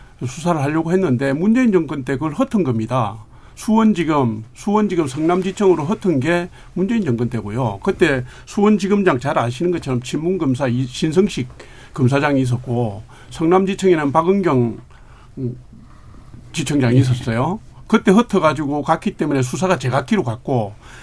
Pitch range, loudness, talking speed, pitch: 125-185 Hz, -18 LUFS, 325 characters per minute, 145 Hz